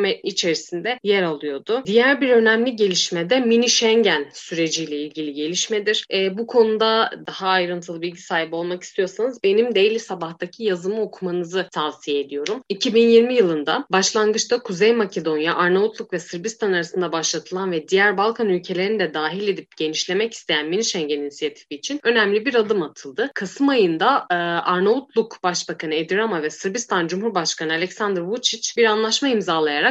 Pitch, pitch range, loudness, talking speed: 190 Hz, 170-225 Hz, -20 LUFS, 140 wpm